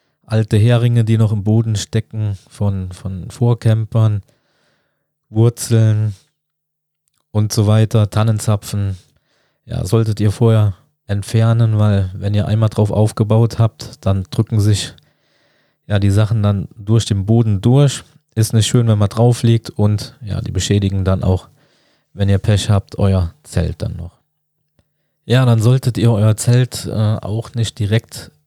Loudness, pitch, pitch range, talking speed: -16 LUFS, 110 Hz, 105-115 Hz, 145 wpm